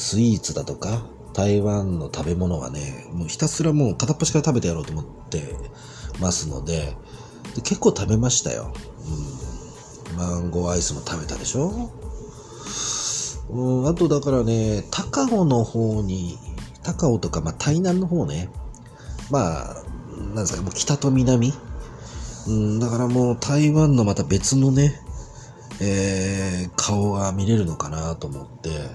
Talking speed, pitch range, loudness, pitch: 280 characters per minute, 85-130 Hz, -23 LUFS, 105 Hz